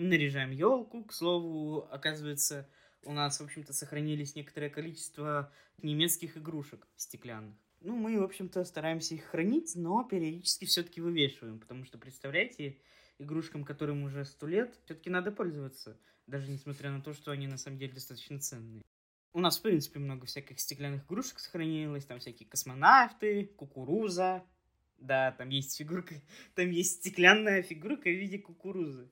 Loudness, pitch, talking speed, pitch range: -33 LUFS, 150 Hz, 150 wpm, 140-180 Hz